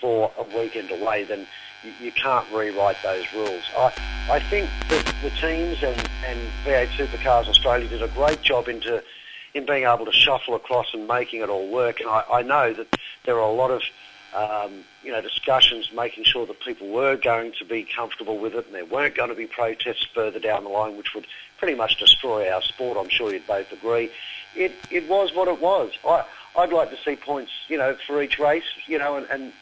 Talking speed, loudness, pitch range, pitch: 220 wpm, -22 LUFS, 110-150 Hz, 120 Hz